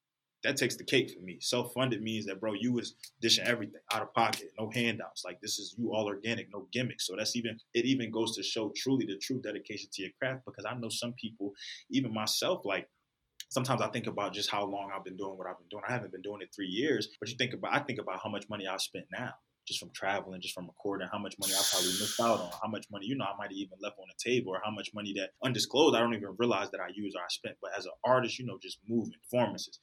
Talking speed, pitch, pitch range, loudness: 275 wpm, 105 Hz, 100-120 Hz, -34 LUFS